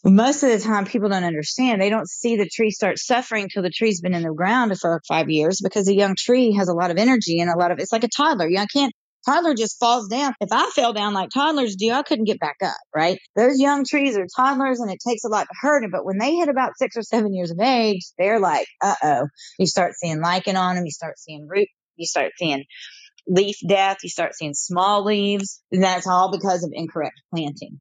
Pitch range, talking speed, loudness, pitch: 180-235 Hz, 250 wpm, -21 LUFS, 200 Hz